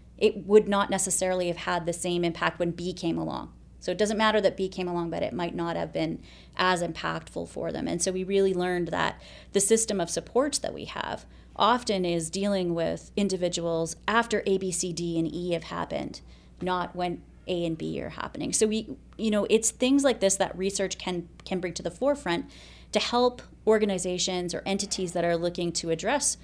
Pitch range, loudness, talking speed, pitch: 170-205 Hz, -27 LUFS, 205 wpm, 185 Hz